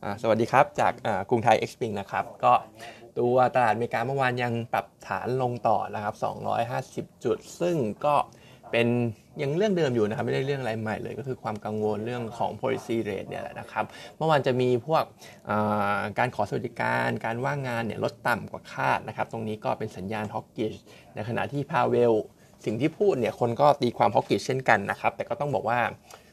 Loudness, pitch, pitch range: -27 LUFS, 115 Hz, 110-130 Hz